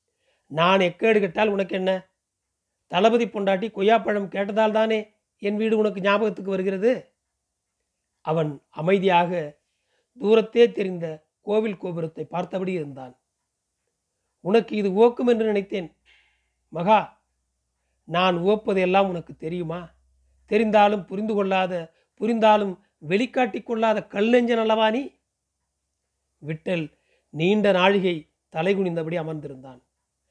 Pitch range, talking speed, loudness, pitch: 160-215 Hz, 90 wpm, -23 LUFS, 190 Hz